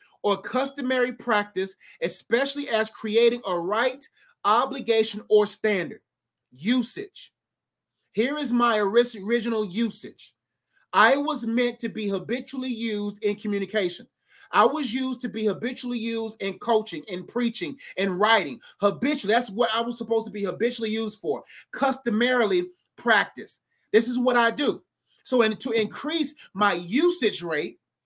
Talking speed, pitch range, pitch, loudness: 140 wpm, 210-250 Hz, 230 Hz, -25 LUFS